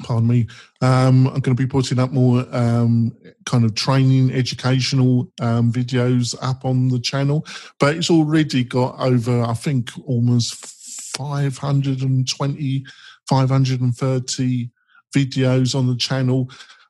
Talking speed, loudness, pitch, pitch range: 125 wpm, -19 LUFS, 130 Hz, 125-135 Hz